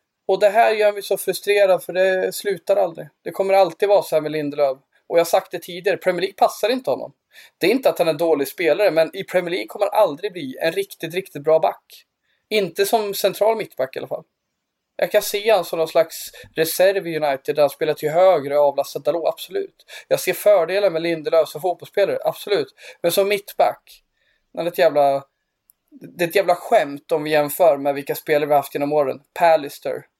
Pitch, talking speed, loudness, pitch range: 180 Hz, 215 wpm, -20 LUFS, 155-200 Hz